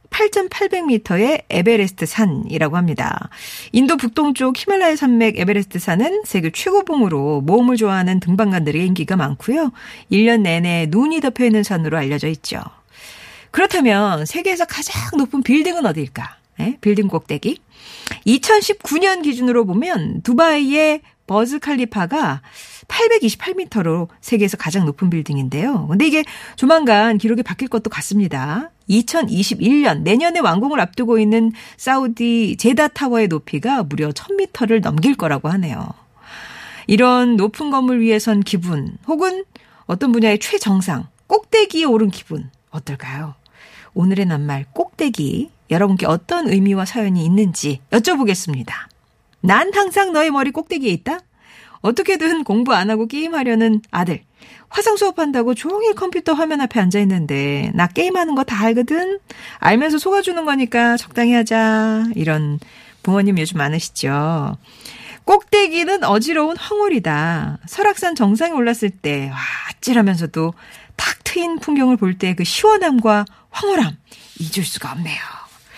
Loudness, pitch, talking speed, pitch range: -17 LUFS, 225 Hz, 305 characters per minute, 185-305 Hz